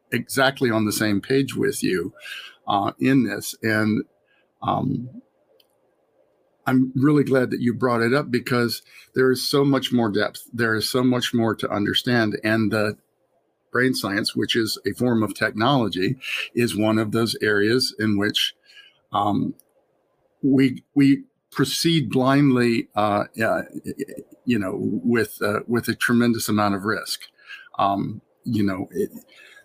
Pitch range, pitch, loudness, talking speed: 110-130 Hz, 120 Hz, -22 LUFS, 145 wpm